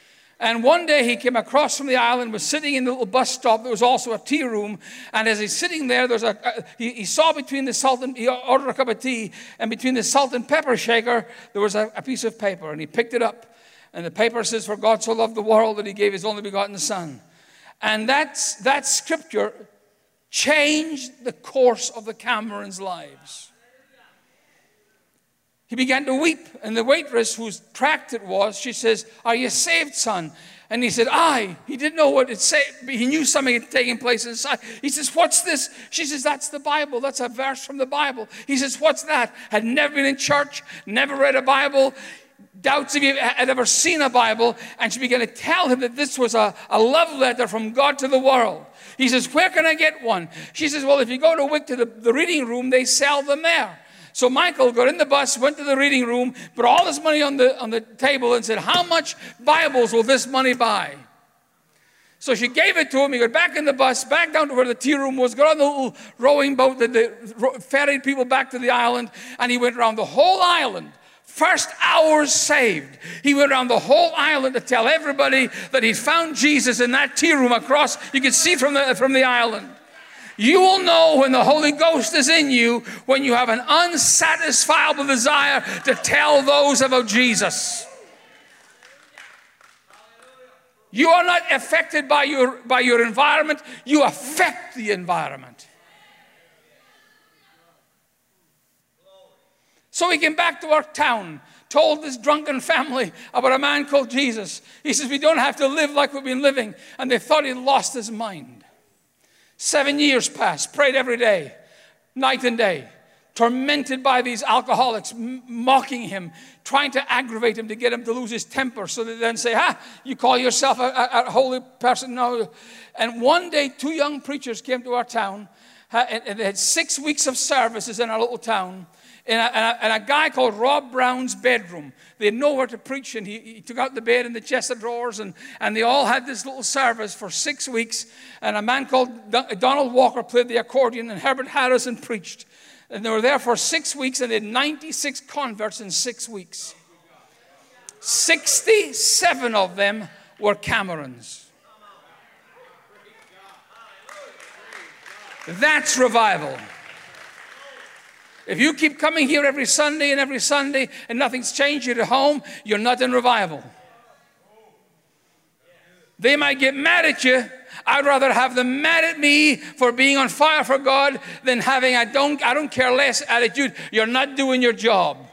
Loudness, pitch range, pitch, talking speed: -19 LUFS, 235-285 Hz, 255 Hz, 190 wpm